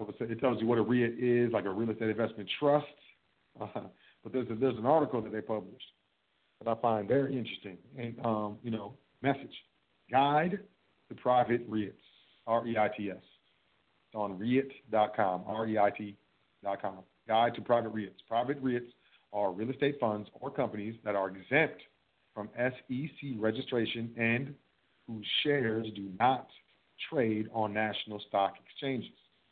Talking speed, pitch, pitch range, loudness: 140 wpm, 115 Hz, 105-130 Hz, -33 LUFS